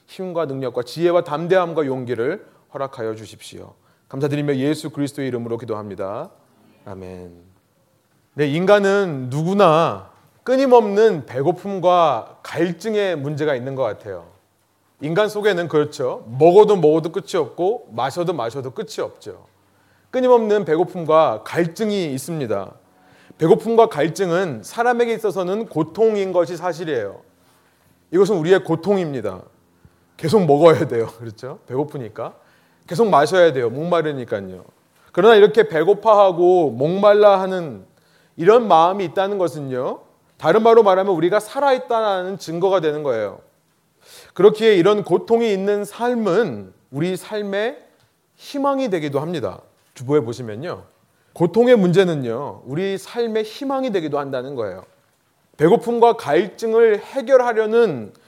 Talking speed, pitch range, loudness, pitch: 310 characters per minute, 145-215 Hz, -18 LUFS, 180 Hz